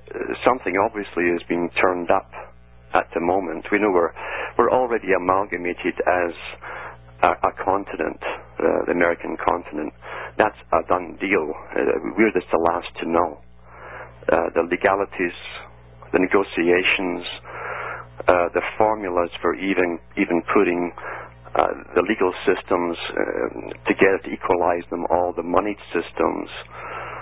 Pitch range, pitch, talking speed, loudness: 65-90 Hz, 85 Hz, 135 wpm, -22 LUFS